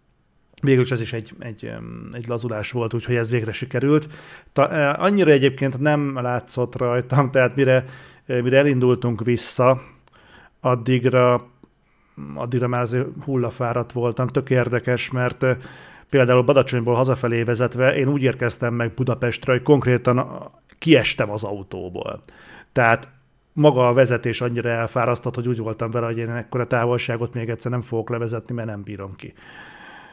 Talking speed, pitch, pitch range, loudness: 140 wpm, 125 Hz, 120-130 Hz, -20 LUFS